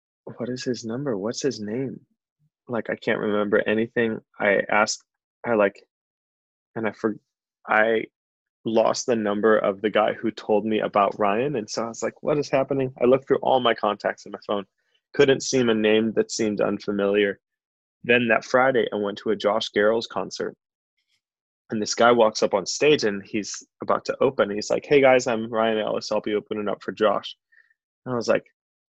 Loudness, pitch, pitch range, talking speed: -23 LUFS, 110 Hz, 105-130 Hz, 195 wpm